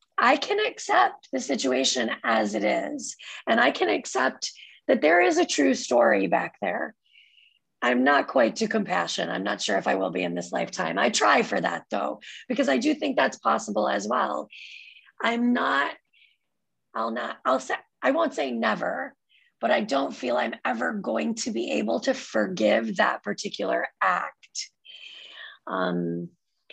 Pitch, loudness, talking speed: 245 Hz, -25 LUFS, 165 wpm